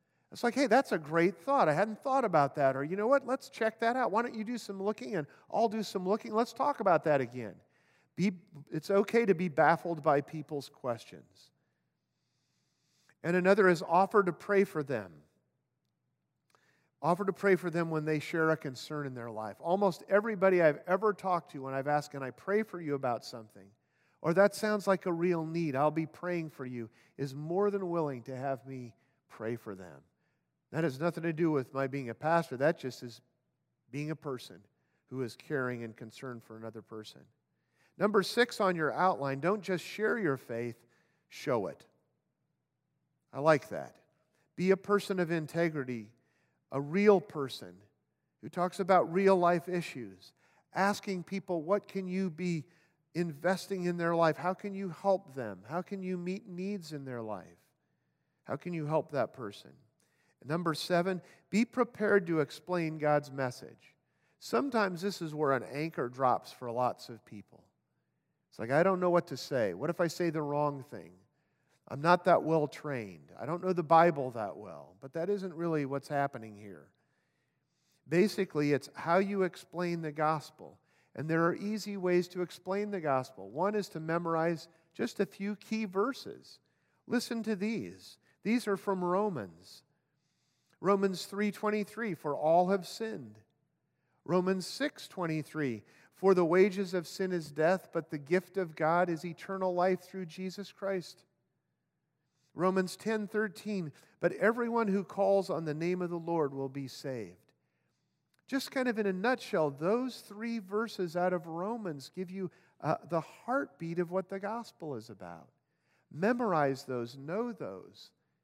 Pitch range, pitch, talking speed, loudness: 140-195 Hz, 170 Hz, 170 wpm, -32 LUFS